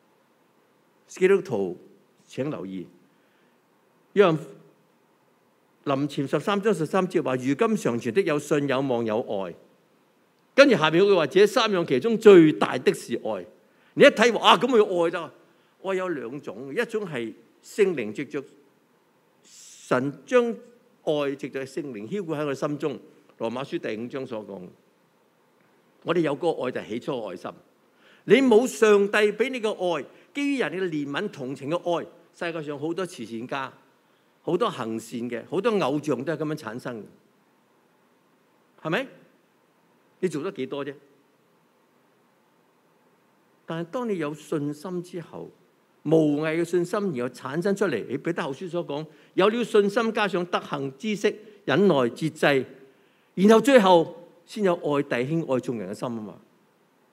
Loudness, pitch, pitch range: -24 LUFS, 165 Hz, 140-205 Hz